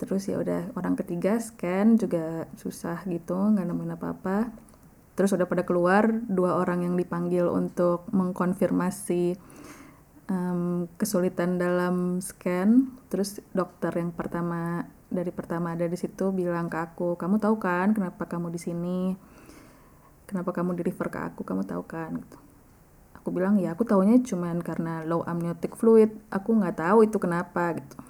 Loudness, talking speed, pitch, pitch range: -27 LUFS, 150 wpm, 180 Hz, 170-195 Hz